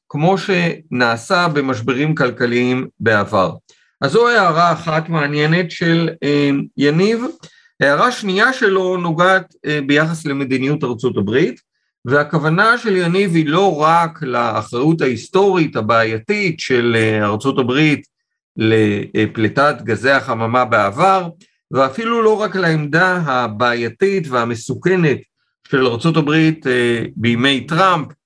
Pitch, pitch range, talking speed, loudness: 150 Hz, 125-180 Hz, 100 wpm, -15 LUFS